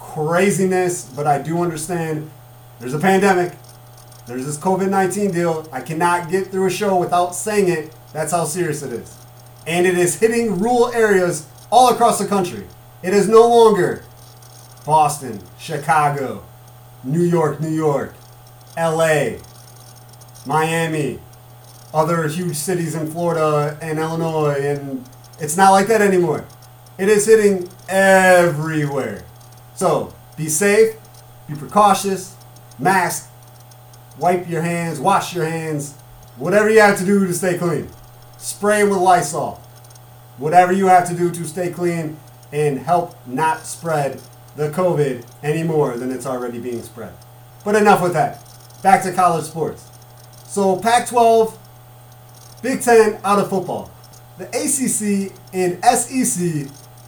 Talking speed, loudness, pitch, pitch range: 135 wpm, -17 LUFS, 155 Hz, 125-185 Hz